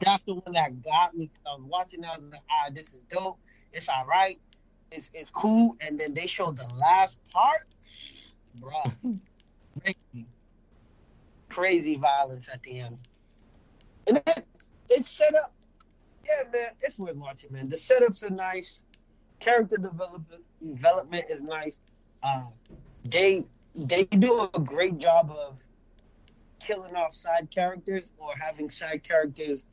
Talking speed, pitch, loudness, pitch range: 145 wpm, 165 Hz, -27 LUFS, 140-190 Hz